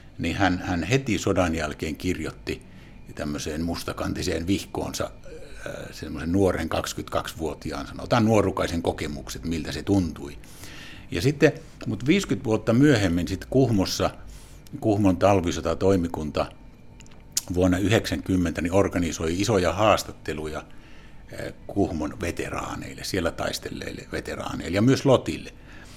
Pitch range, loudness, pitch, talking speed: 85-110 Hz, -25 LUFS, 95 Hz, 100 wpm